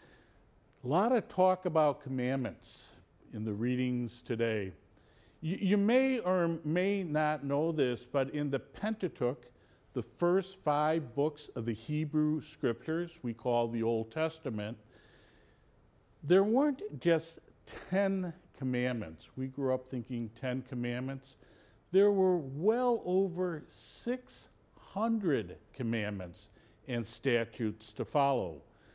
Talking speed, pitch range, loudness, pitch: 115 wpm, 115-175 Hz, -33 LUFS, 135 Hz